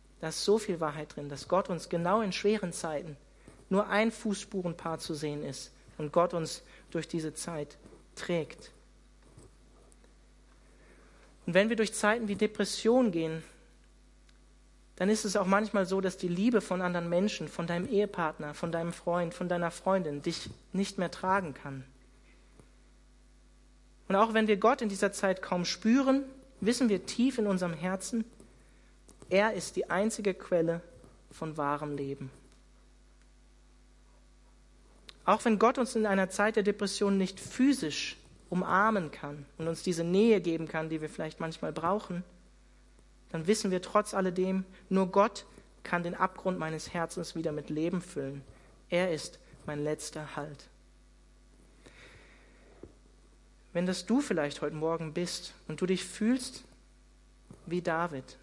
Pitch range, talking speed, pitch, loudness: 160-205 Hz, 145 wpm, 180 Hz, -31 LUFS